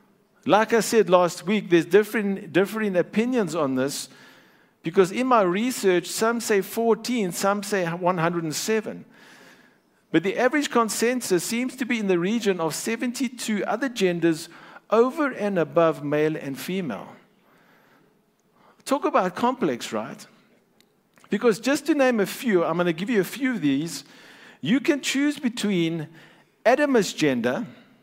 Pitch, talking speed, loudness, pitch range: 210 Hz, 140 wpm, -23 LUFS, 180-240 Hz